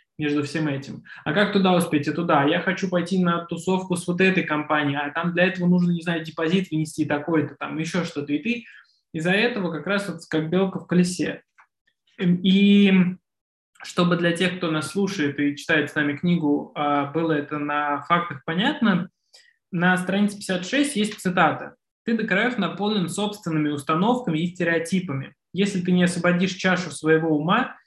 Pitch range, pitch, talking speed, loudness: 155-190 Hz, 175 Hz, 170 wpm, -23 LUFS